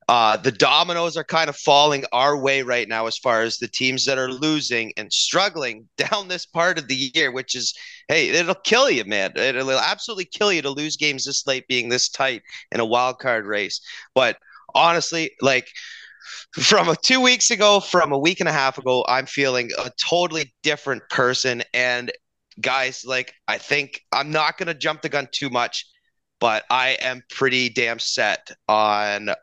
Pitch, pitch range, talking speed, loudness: 135 Hz, 125-165 Hz, 190 wpm, -20 LUFS